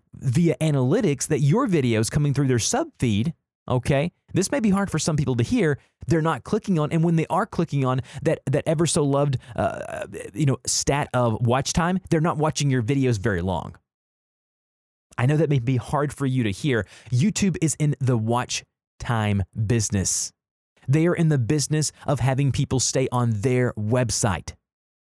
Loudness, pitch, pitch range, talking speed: -23 LUFS, 135 Hz, 120-155 Hz, 185 wpm